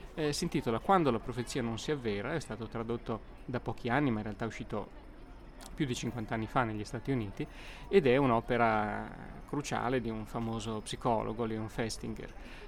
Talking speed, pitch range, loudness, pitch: 180 wpm, 110-130 Hz, -34 LUFS, 115 Hz